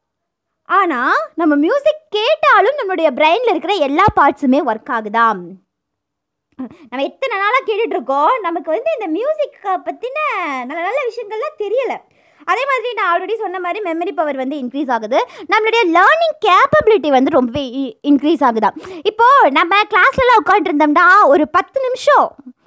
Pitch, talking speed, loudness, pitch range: 345 Hz, 130 wpm, -14 LUFS, 290-410 Hz